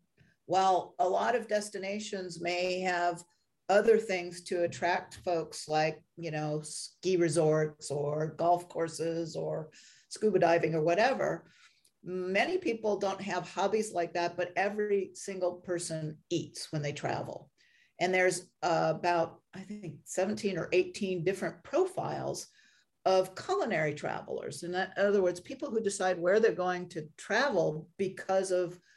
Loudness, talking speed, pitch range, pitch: -32 LUFS, 145 wpm, 165-195 Hz, 180 Hz